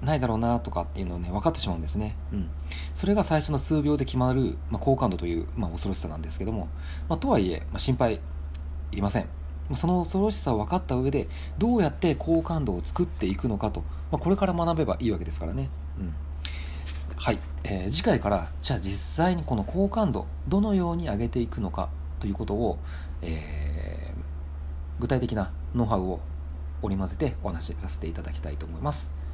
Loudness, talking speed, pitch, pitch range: -28 LUFS, 425 characters per minute, 80 Hz, 75-115 Hz